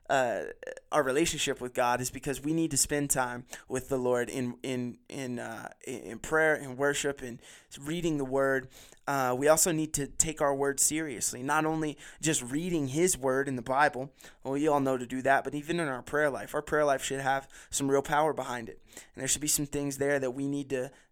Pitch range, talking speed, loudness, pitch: 130-150 Hz, 225 wpm, -30 LUFS, 140 Hz